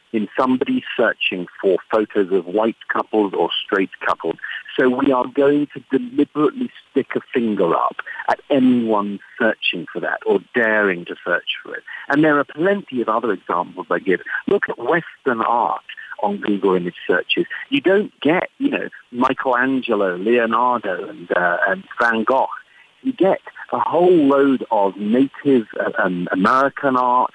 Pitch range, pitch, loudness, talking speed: 115-145 Hz, 130 Hz, -19 LUFS, 160 wpm